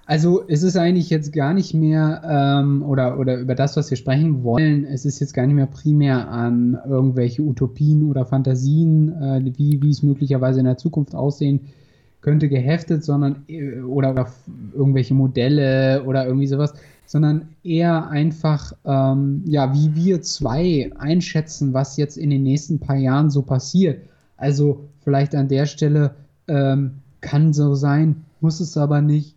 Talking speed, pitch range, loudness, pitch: 165 wpm, 135-155 Hz, -19 LUFS, 145 Hz